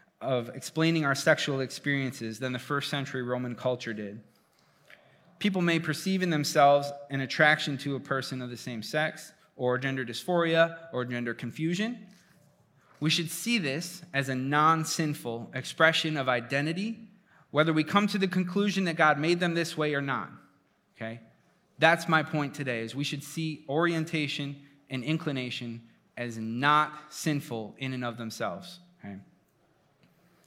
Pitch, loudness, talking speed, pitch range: 150 Hz, -29 LUFS, 150 wpm, 130-165 Hz